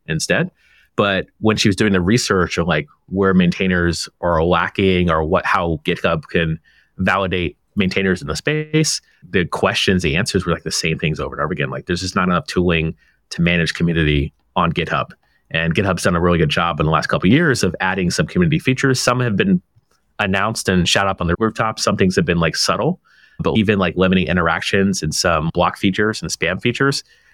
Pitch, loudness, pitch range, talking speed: 95 Hz, -18 LUFS, 85-110 Hz, 205 wpm